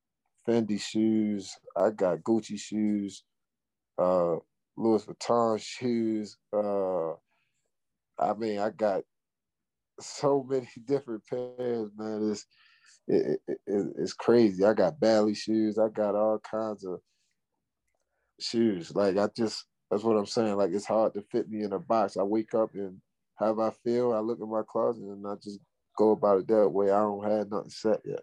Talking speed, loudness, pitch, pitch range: 170 wpm, -29 LUFS, 110 Hz, 105-115 Hz